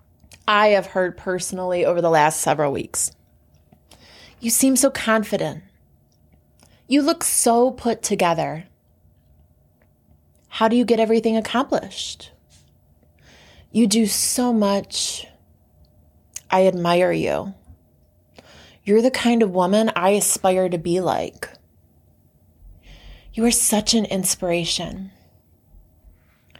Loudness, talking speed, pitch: -19 LUFS, 105 wpm, 170 Hz